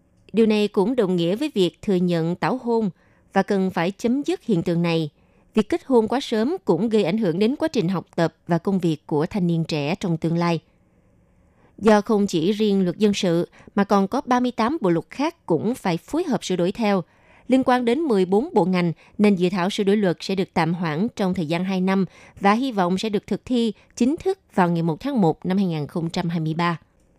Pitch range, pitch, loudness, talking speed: 170-220 Hz, 195 Hz, -22 LUFS, 225 wpm